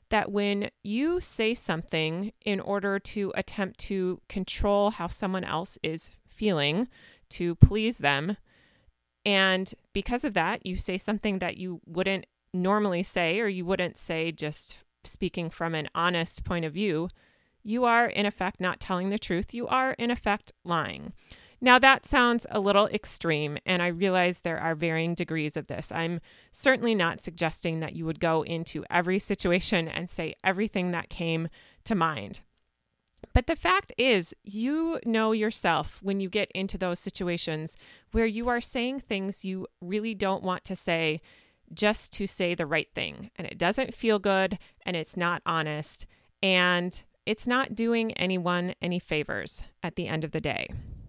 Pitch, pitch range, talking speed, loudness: 185 Hz, 170-210 Hz, 165 wpm, -28 LUFS